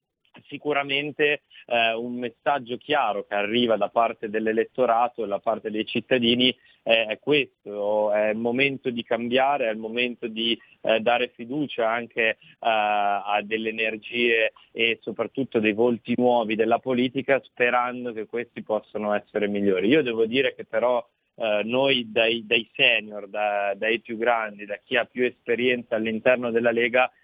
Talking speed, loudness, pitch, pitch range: 150 wpm, -24 LUFS, 115 Hz, 110-125 Hz